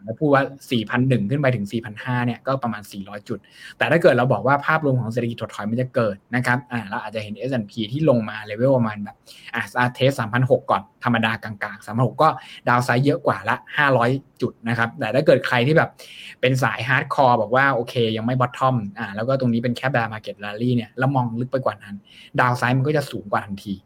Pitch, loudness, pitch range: 120 Hz, -21 LUFS, 110-130 Hz